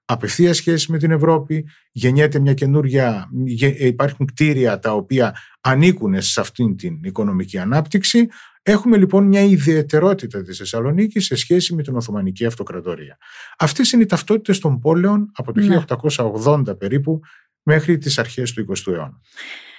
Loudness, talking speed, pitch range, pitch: -17 LUFS, 140 wpm, 125-180 Hz, 150 Hz